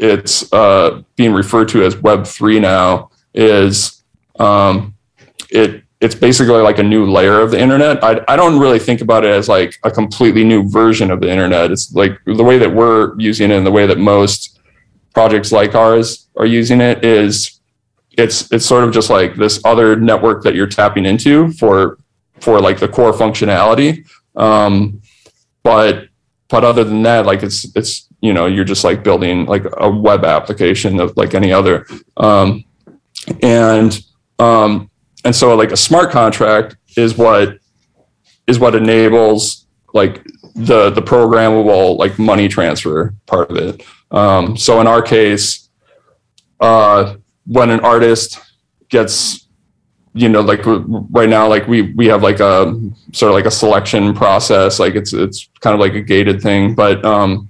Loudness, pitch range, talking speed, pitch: -11 LUFS, 100-115 Hz, 170 wpm, 110 Hz